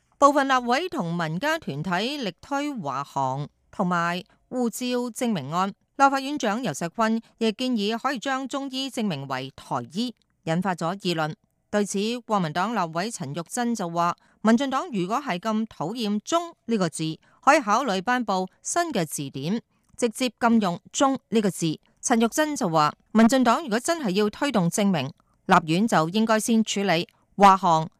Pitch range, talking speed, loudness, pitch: 175-245 Hz, 250 characters per minute, -24 LUFS, 215 Hz